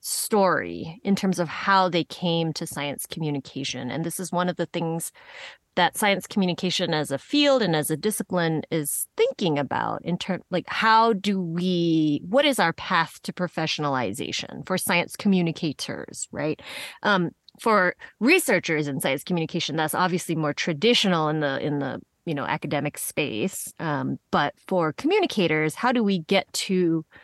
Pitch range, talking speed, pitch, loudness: 155-195 Hz, 160 wpm, 175 Hz, -24 LUFS